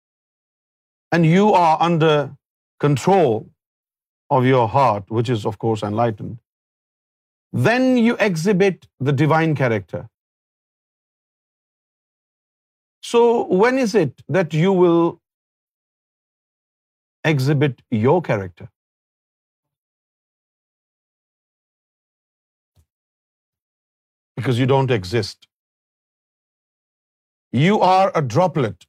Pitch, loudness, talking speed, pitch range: 140 Hz, -18 LUFS, 80 wpm, 115-170 Hz